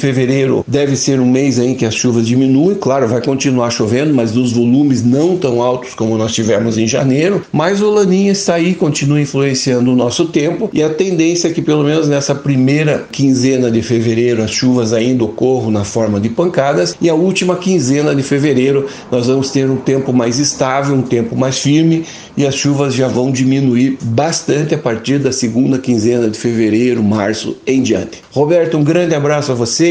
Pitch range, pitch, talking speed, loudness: 120-150 Hz, 135 Hz, 190 wpm, -13 LUFS